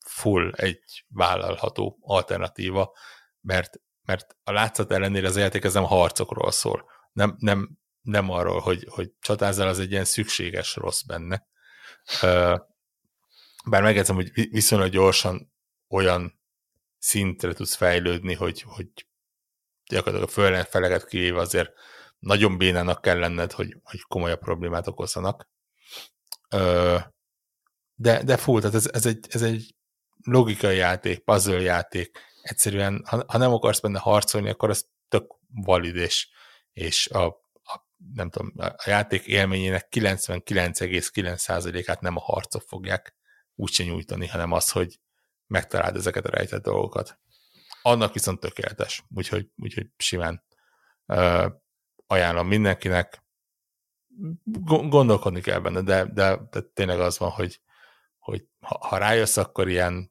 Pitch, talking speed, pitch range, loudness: 95 Hz, 130 wpm, 90-105 Hz, -24 LUFS